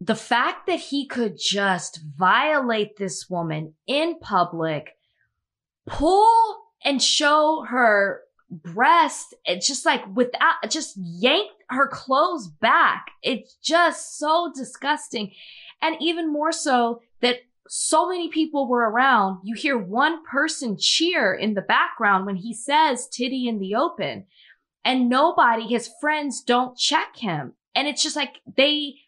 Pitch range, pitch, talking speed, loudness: 225-315 Hz, 260 Hz, 135 wpm, -21 LUFS